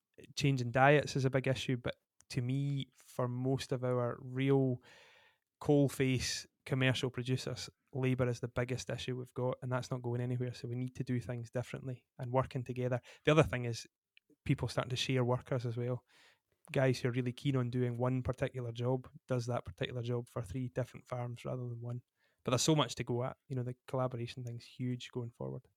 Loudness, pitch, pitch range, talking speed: -36 LUFS, 125 Hz, 125-135 Hz, 205 wpm